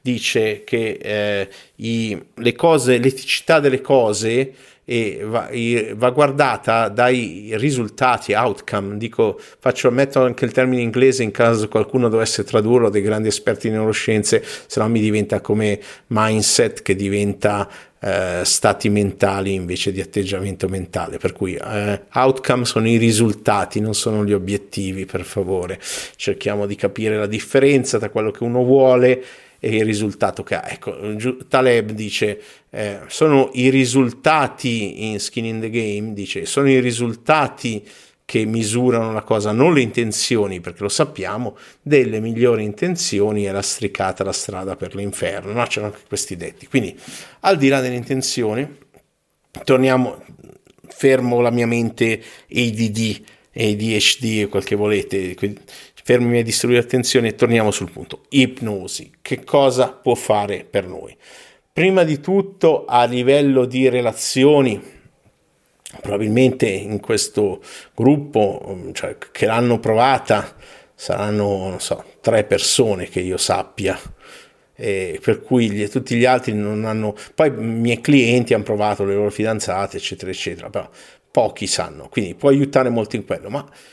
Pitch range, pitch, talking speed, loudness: 105-130 Hz, 115 Hz, 145 wpm, -18 LUFS